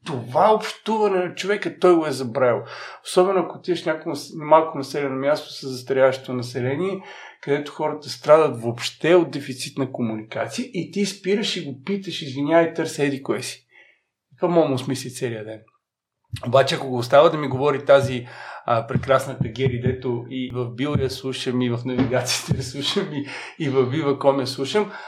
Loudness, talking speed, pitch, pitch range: -22 LUFS, 175 wpm, 140 Hz, 130-165 Hz